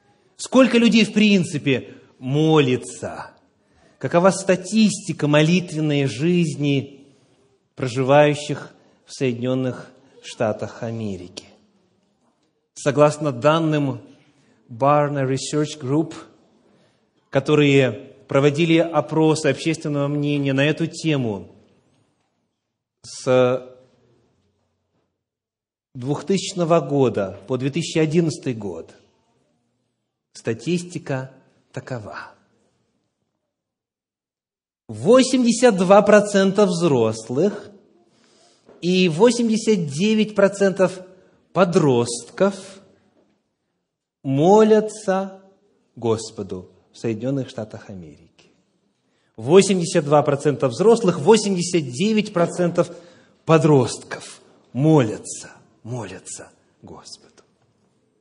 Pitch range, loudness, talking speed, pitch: 130-185 Hz, -19 LUFS, 55 wpm, 150 Hz